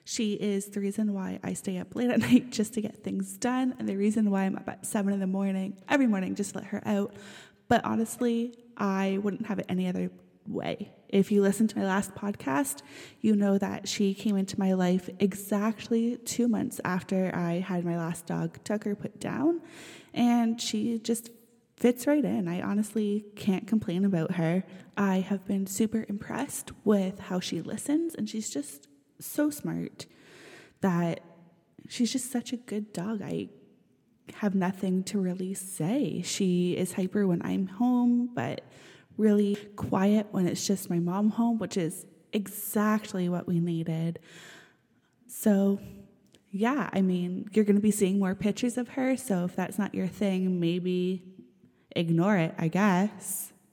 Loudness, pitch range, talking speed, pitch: -29 LUFS, 185-220 Hz, 170 wpm, 200 Hz